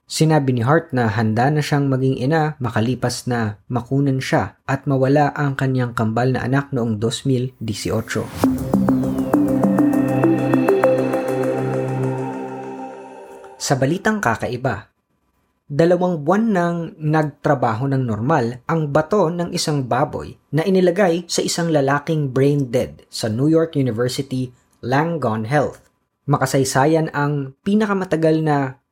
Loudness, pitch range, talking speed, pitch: -19 LUFS, 115-155 Hz, 110 wpm, 135 Hz